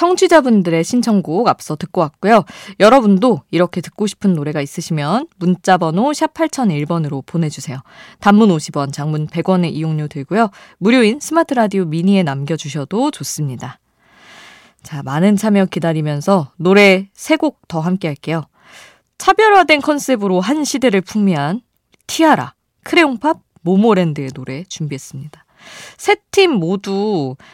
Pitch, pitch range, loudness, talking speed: 185 Hz, 155-230 Hz, -15 LUFS, 305 characters per minute